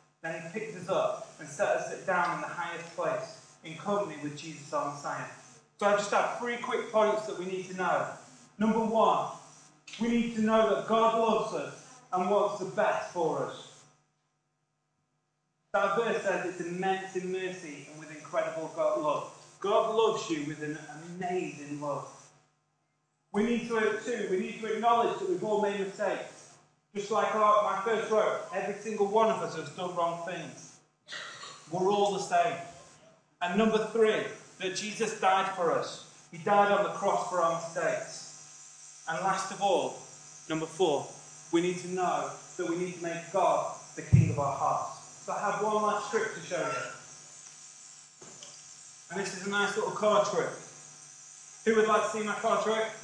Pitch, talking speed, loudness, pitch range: 195 Hz, 180 wpm, -30 LUFS, 165-215 Hz